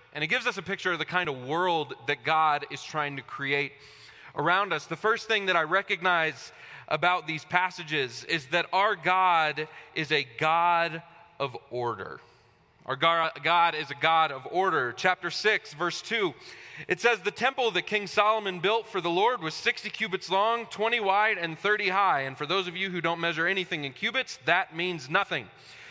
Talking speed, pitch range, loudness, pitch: 190 wpm, 155-195 Hz, -27 LUFS, 175 Hz